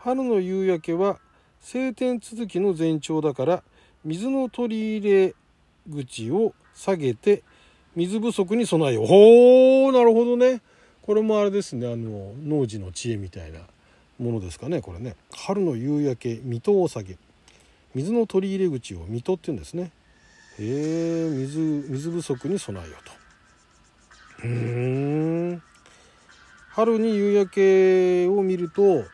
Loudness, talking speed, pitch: -22 LUFS, 250 characters per minute, 165 Hz